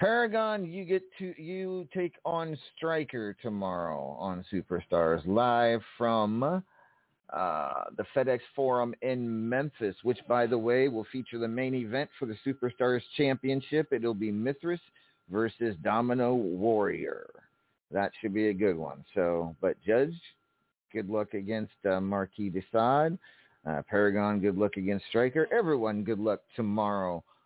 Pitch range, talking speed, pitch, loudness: 105-140 Hz, 140 wpm, 120 Hz, -31 LUFS